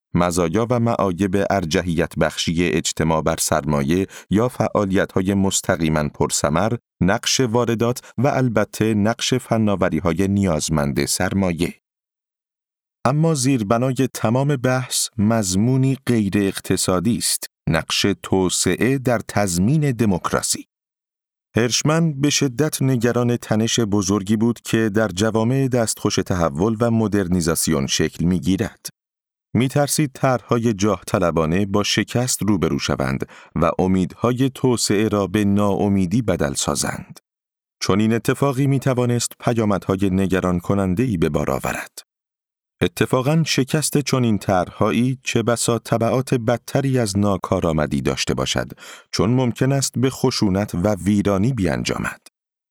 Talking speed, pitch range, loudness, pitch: 115 wpm, 95-125 Hz, -20 LUFS, 105 Hz